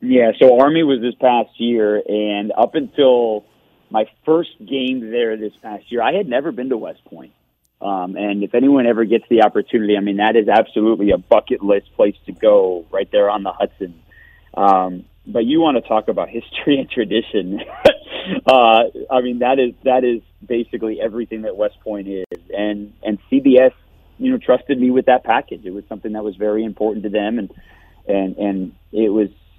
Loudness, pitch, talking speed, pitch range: -17 LUFS, 115 Hz, 195 wpm, 105-130 Hz